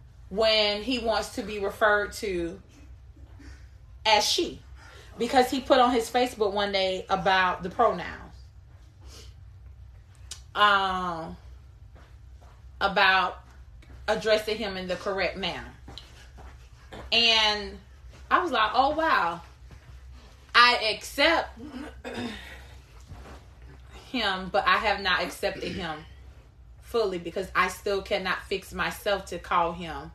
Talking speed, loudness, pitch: 105 wpm, -25 LUFS, 190 Hz